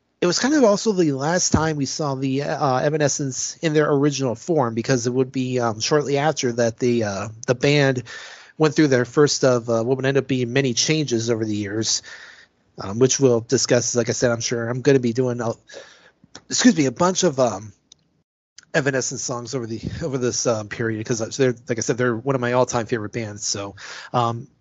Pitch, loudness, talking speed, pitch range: 130 Hz, -21 LUFS, 215 wpm, 120-145 Hz